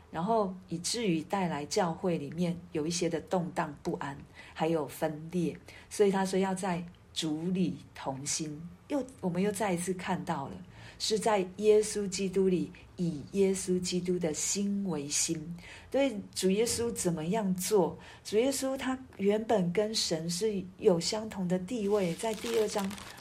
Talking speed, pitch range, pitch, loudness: 220 characters per minute, 170-210 Hz, 185 Hz, -31 LUFS